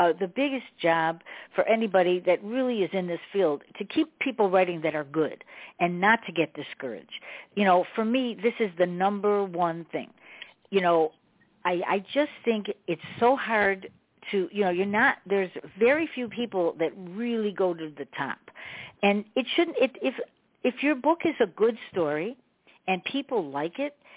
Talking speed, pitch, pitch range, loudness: 185 wpm, 200 Hz, 175-235 Hz, -27 LUFS